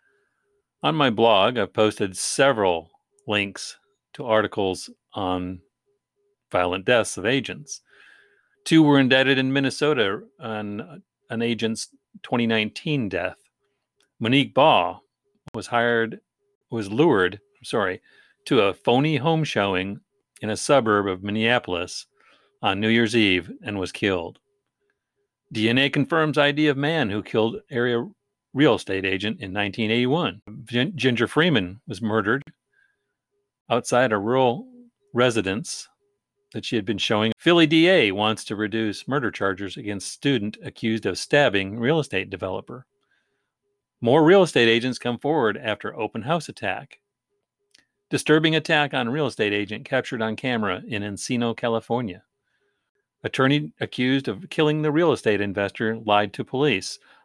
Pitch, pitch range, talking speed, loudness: 125 Hz, 110-160 Hz, 130 wpm, -22 LUFS